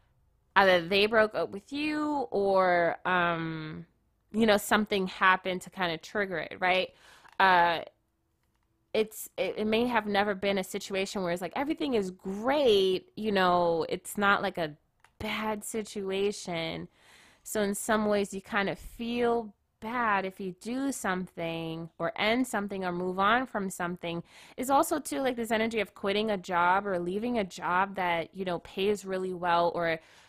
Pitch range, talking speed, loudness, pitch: 180-220 Hz, 165 wpm, -29 LUFS, 195 Hz